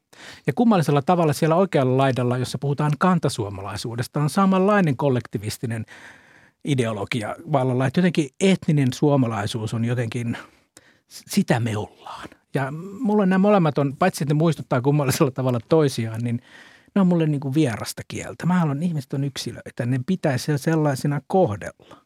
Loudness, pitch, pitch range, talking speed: -22 LUFS, 145 Hz, 125-165 Hz, 140 wpm